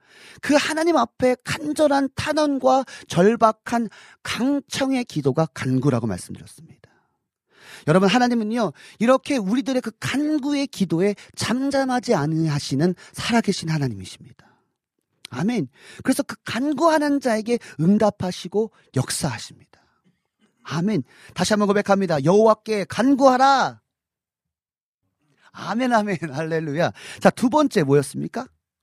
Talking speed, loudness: 280 characters per minute, -21 LUFS